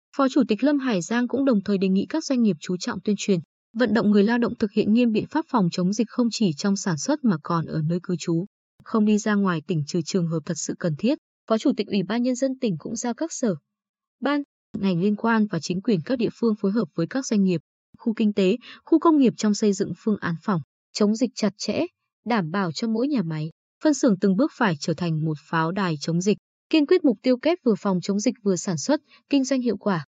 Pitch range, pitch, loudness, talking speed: 185-245 Hz, 210 Hz, -24 LUFS, 265 wpm